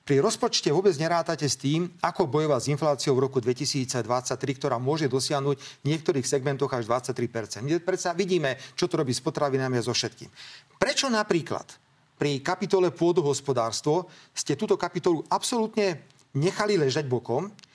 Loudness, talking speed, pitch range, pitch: -26 LUFS, 150 wpm, 135-180 Hz, 145 Hz